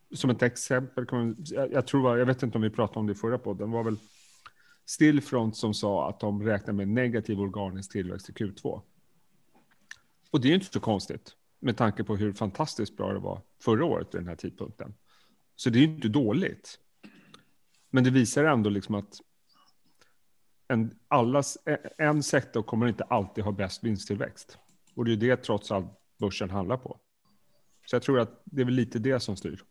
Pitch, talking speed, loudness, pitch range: 115 Hz, 185 wpm, -28 LUFS, 105-125 Hz